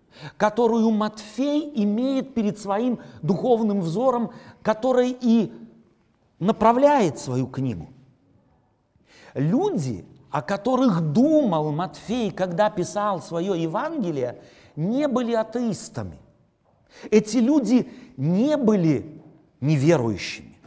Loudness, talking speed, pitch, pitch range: -23 LUFS, 85 wpm, 210 Hz, 155-240 Hz